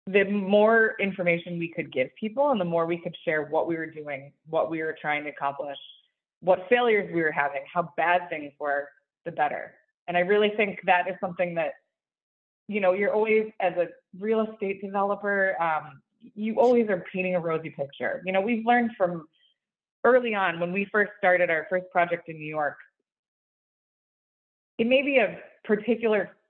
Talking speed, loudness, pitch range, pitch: 185 wpm, -26 LUFS, 160-210 Hz, 180 Hz